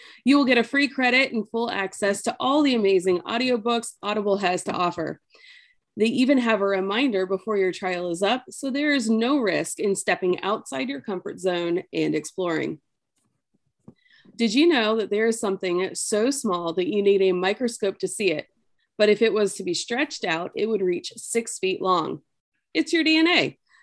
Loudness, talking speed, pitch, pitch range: -23 LUFS, 190 wpm, 215 Hz, 190-255 Hz